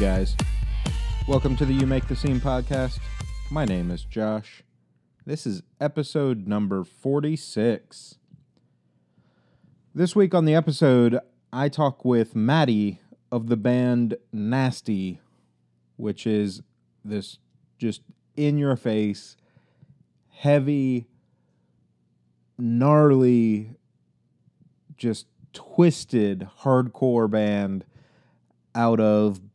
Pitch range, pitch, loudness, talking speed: 100-135 Hz, 115 Hz, -24 LUFS, 95 wpm